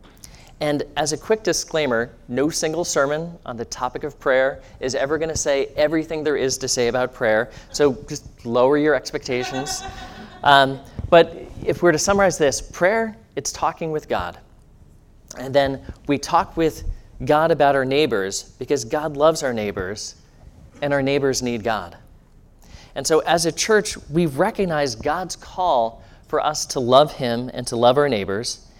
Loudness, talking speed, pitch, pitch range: -21 LUFS, 165 wpm, 145 Hz, 125-155 Hz